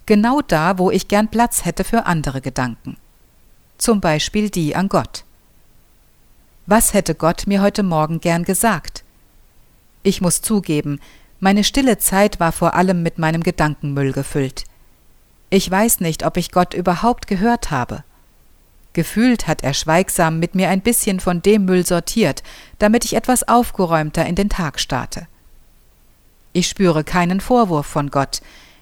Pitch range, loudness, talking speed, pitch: 155-205 Hz, -17 LUFS, 150 wpm, 180 Hz